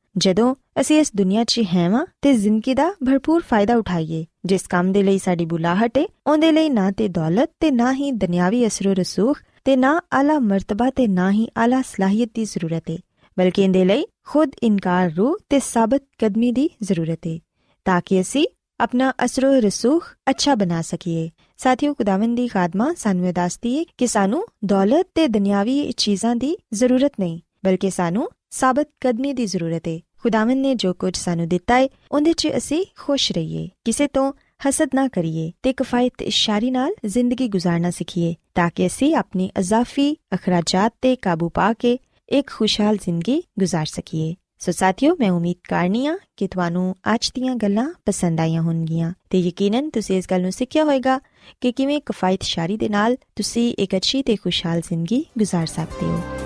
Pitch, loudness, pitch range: 215 Hz, -20 LUFS, 185-265 Hz